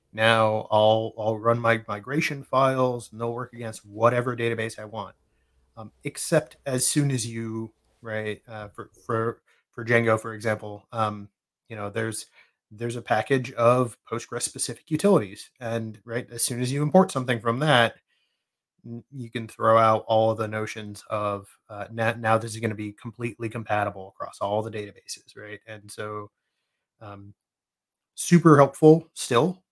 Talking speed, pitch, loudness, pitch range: 165 wpm, 115 Hz, -24 LUFS, 110-120 Hz